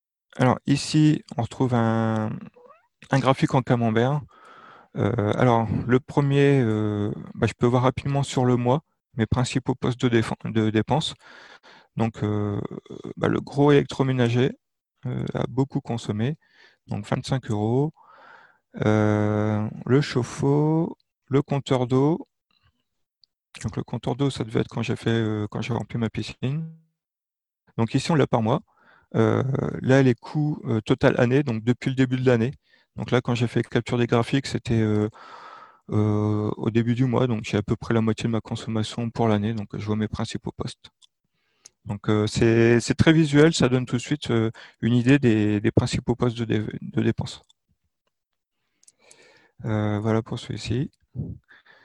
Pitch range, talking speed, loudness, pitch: 110-135 Hz, 165 wpm, -23 LUFS, 120 Hz